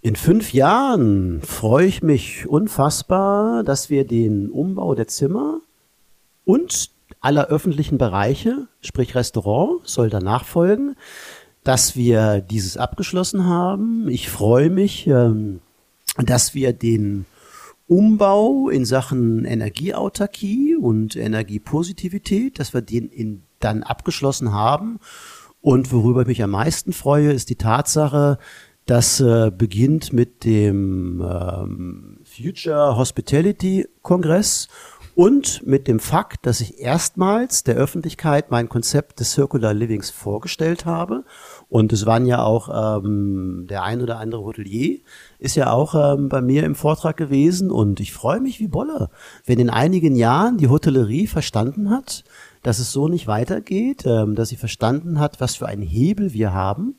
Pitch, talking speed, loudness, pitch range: 130 Hz, 135 wpm, -19 LUFS, 110-170 Hz